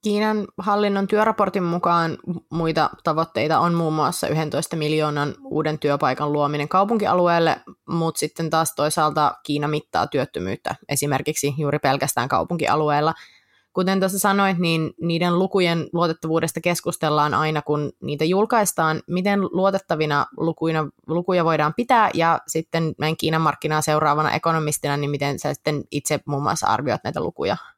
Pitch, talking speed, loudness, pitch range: 160 Hz, 130 wpm, -21 LUFS, 150-175 Hz